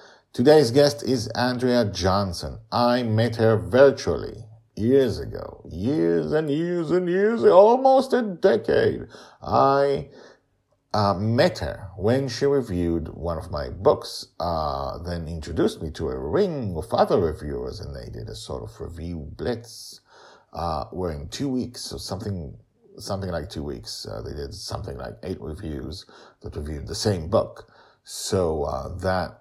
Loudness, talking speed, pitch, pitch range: -23 LUFS, 150 wpm, 110 Hz, 85-135 Hz